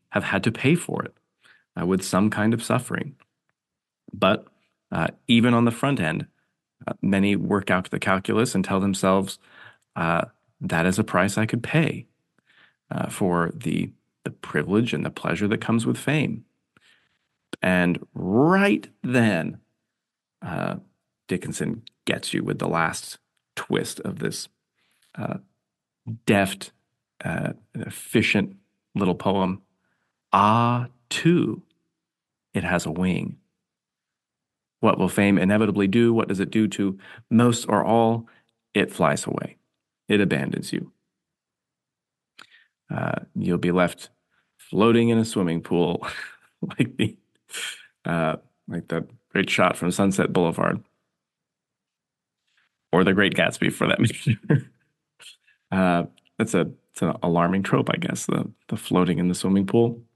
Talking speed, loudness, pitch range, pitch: 135 wpm, -23 LUFS, 95-115 Hz, 100 Hz